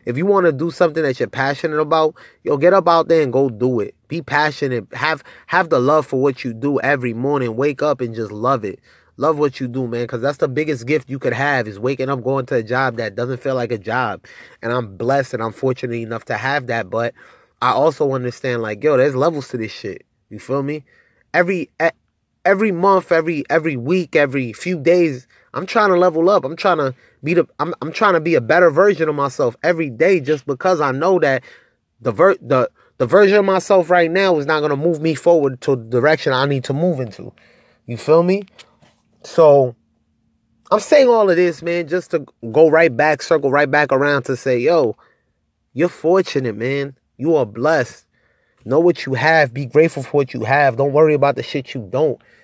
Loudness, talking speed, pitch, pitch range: -17 LUFS, 220 wpm, 145 Hz, 130-165 Hz